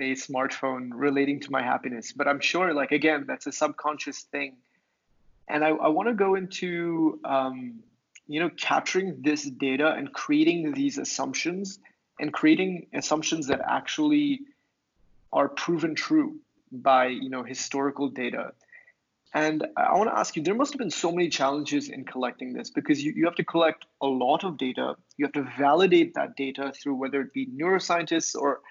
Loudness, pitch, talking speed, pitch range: -26 LUFS, 155 Hz, 175 wpm, 135-190 Hz